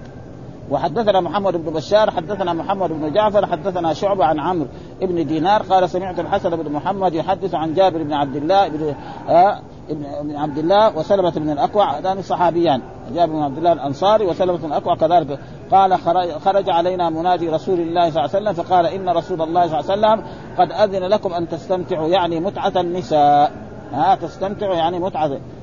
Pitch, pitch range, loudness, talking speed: 175 Hz, 155-195 Hz, -18 LUFS, 170 wpm